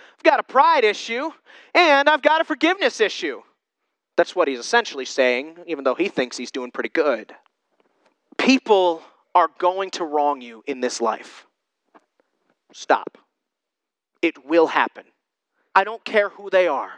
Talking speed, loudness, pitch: 150 wpm, -20 LUFS, 180 Hz